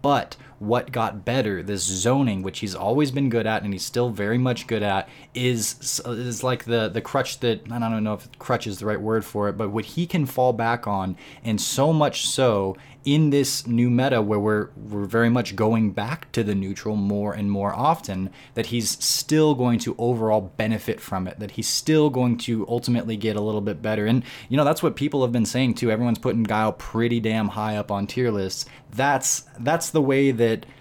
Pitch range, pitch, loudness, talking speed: 105-130 Hz, 115 Hz, -23 LUFS, 215 wpm